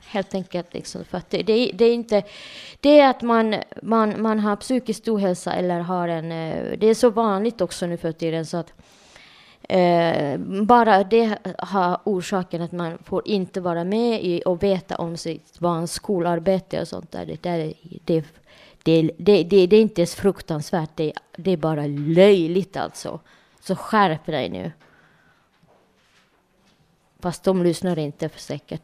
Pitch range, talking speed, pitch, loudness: 170-205 Hz, 160 wpm, 185 Hz, -21 LUFS